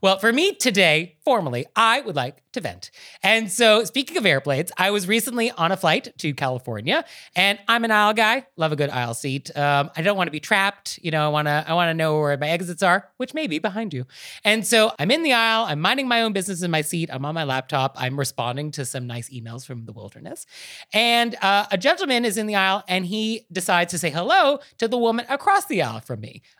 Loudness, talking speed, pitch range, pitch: -21 LUFS, 240 wpm, 150-225 Hz, 185 Hz